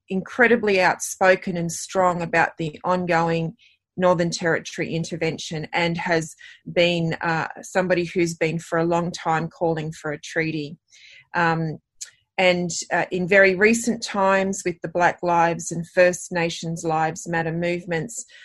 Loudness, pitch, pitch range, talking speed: -22 LUFS, 170 Hz, 165-185 Hz, 135 wpm